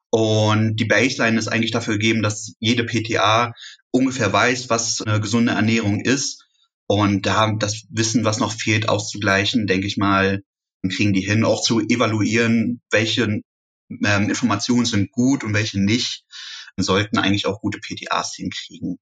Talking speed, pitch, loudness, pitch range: 160 wpm, 110 Hz, -19 LUFS, 105-115 Hz